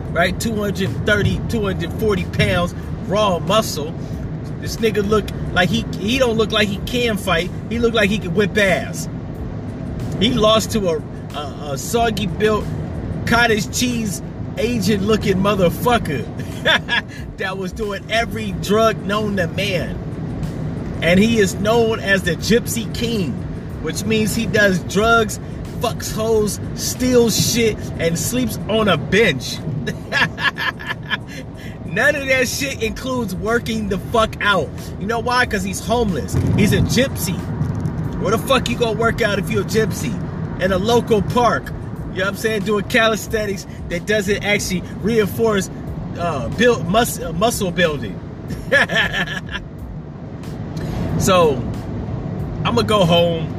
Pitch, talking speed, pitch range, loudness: 210 Hz, 135 wpm, 185-225 Hz, -19 LUFS